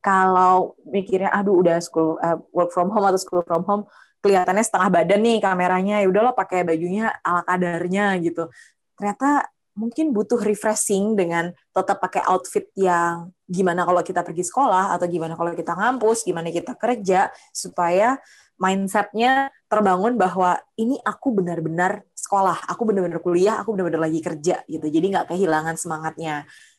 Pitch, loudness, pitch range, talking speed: 185 Hz, -21 LUFS, 175-210 Hz, 150 wpm